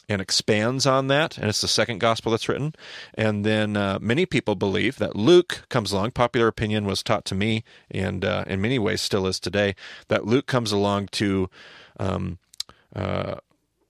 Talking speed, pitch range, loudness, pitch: 180 wpm, 100-125 Hz, -23 LUFS, 110 Hz